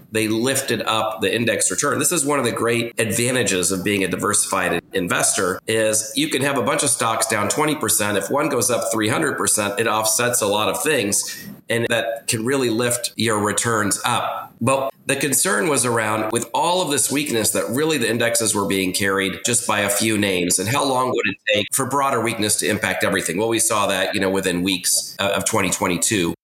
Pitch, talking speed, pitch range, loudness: 110 Hz, 205 wpm, 100-120 Hz, -19 LUFS